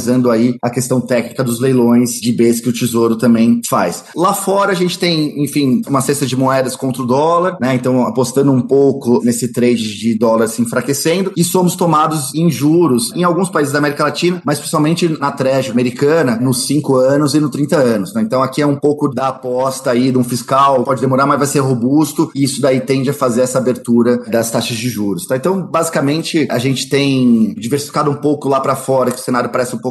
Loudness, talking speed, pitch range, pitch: -14 LUFS, 215 wpm, 125-145 Hz, 135 Hz